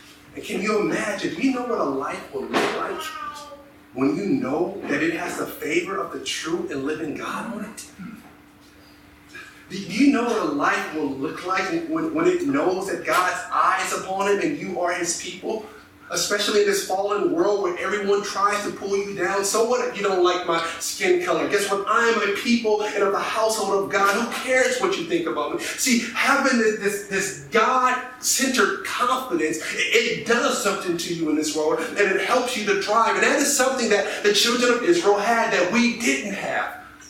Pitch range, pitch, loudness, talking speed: 195-260 Hz, 220 Hz, -22 LUFS, 205 wpm